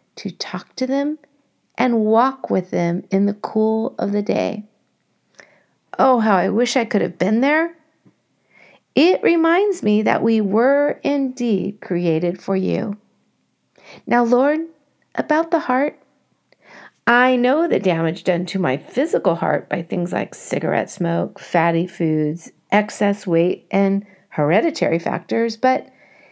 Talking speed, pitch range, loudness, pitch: 135 wpm, 185-260 Hz, -19 LUFS, 215 Hz